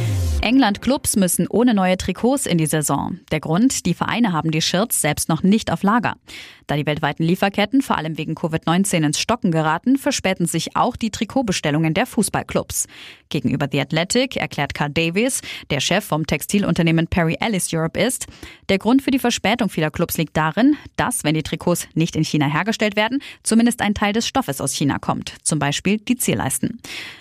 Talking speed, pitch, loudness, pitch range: 185 wpm, 175 Hz, -19 LUFS, 155-225 Hz